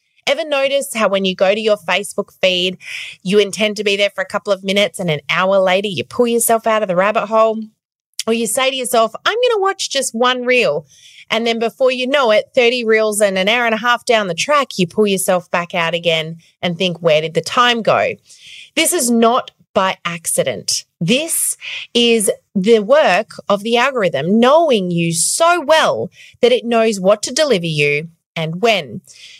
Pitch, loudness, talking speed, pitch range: 215 Hz, -15 LUFS, 200 wpm, 185-250 Hz